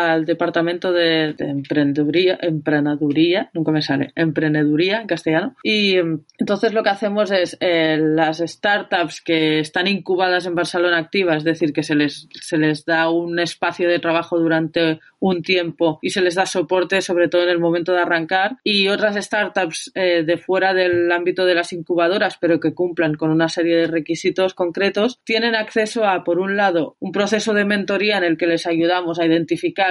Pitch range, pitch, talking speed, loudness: 165-190 Hz, 175 Hz, 180 wpm, -18 LUFS